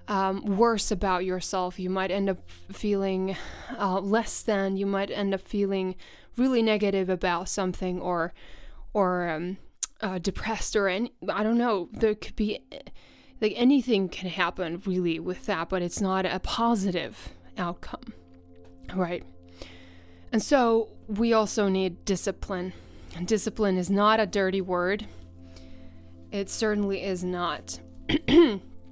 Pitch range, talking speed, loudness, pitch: 175-210 Hz, 135 wpm, -27 LUFS, 190 Hz